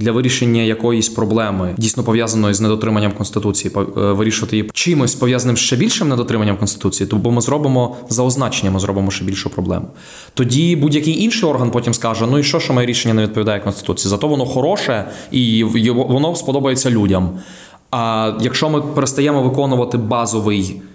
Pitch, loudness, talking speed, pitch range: 115 Hz, -15 LUFS, 165 wpm, 105-130 Hz